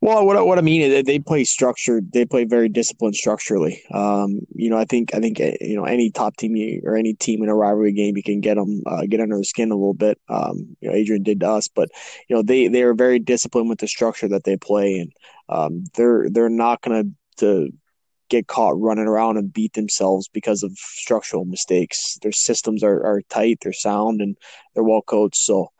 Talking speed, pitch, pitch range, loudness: 230 wpm, 110 Hz, 105-120 Hz, -19 LUFS